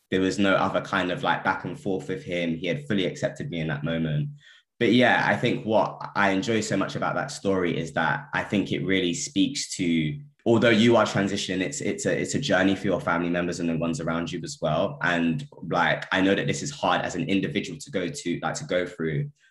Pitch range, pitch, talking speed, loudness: 85-100 Hz, 90 Hz, 245 wpm, -25 LUFS